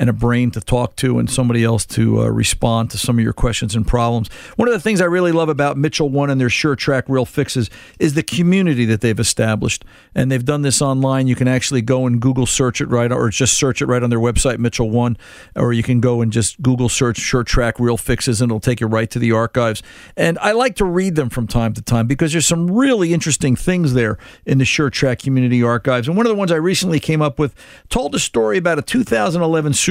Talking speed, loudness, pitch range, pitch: 245 wpm, -16 LUFS, 115-150 Hz, 125 Hz